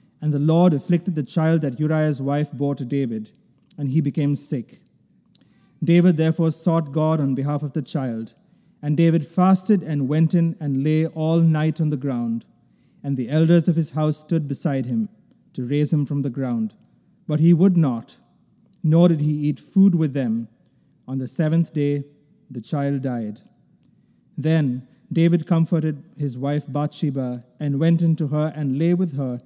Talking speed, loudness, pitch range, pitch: 175 wpm, -21 LUFS, 140-165 Hz, 155 Hz